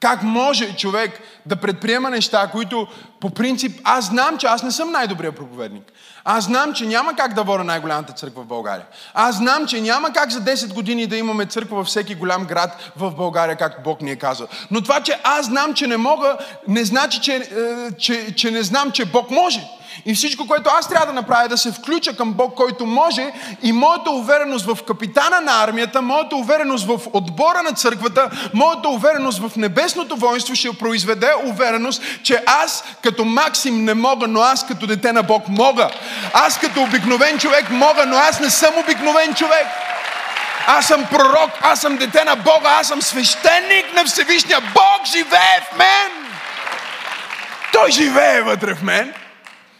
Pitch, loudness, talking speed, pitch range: 250 Hz, -16 LUFS, 180 wpm, 225-295 Hz